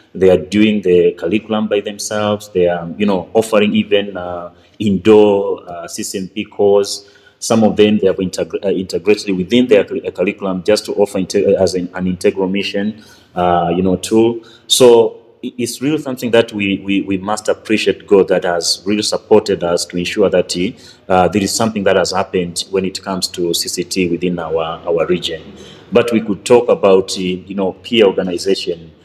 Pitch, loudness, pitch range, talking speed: 100 Hz, -15 LUFS, 90-105 Hz, 180 wpm